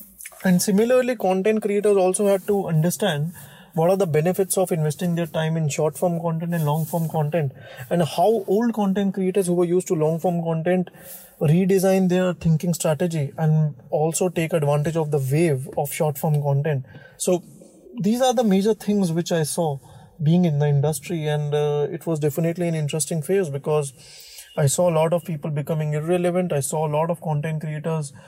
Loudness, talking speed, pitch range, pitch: -22 LUFS, 185 wpm, 155-185 Hz, 170 Hz